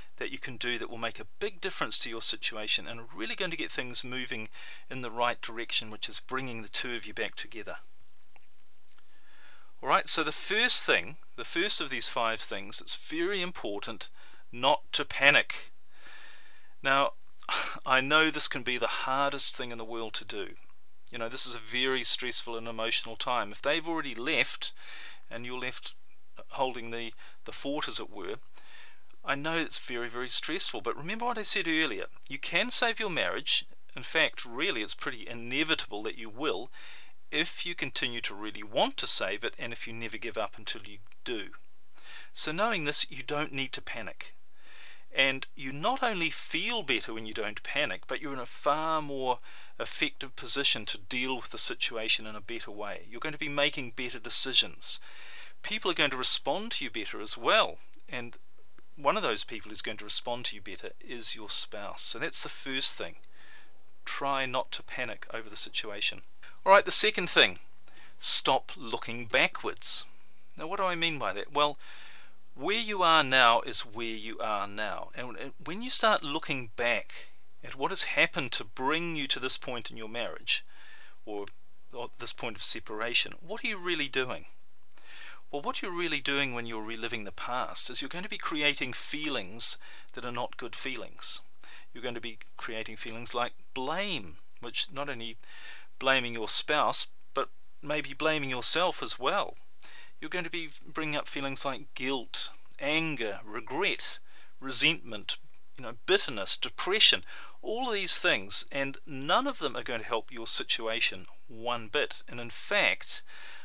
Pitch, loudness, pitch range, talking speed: 130 Hz, -30 LUFS, 115-160 Hz, 180 wpm